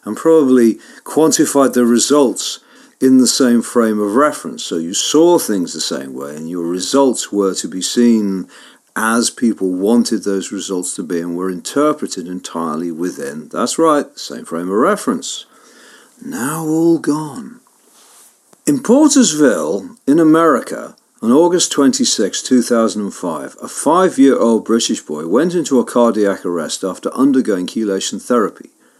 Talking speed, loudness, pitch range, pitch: 140 wpm, -15 LUFS, 100-155 Hz, 120 Hz